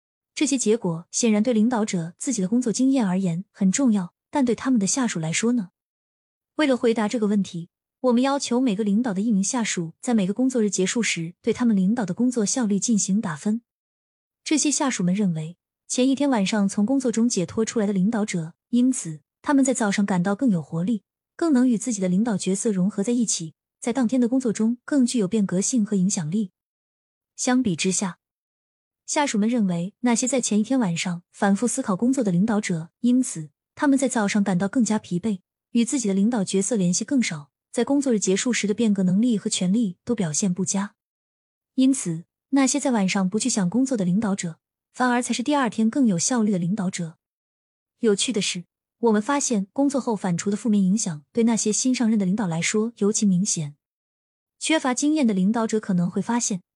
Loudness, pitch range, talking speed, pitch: -23 LUFS, 190-245 Hz, 310 characters per minute, 215 Hz